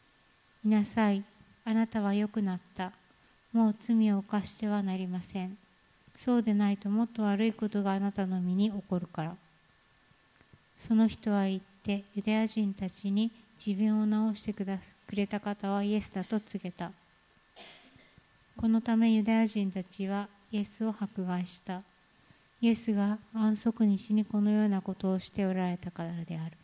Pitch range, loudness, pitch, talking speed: 190-215 Hz, -31 LUFS, 205 Hz, 295 characters per minute